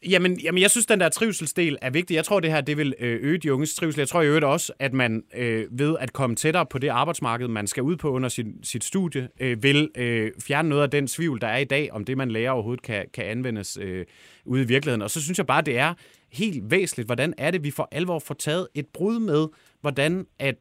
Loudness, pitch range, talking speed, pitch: -24 LUFS, 125-165 Hz, 245 wpm, 145 Hz